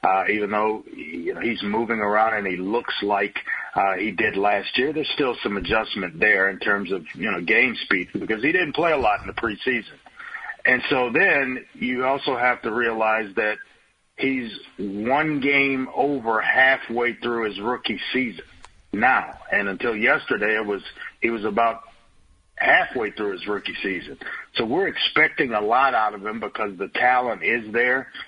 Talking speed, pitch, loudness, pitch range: 175 wpm, 110 Hz, -22 LUFS, 105-125 Hz